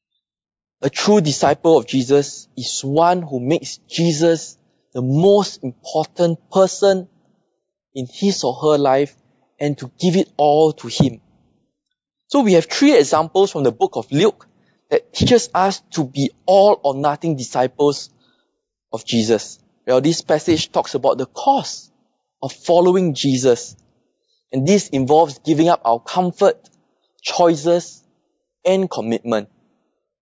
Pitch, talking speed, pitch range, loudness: 165 Hz, 135 wpm, 135-190 Hz, -17 LUFS